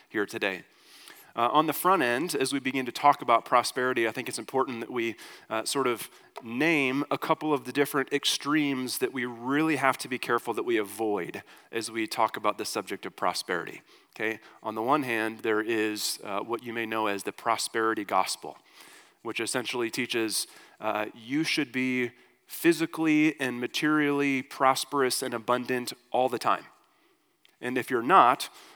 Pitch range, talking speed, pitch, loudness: 115-140 Hz, 175 wpm, 130 Hz, -28 LUFS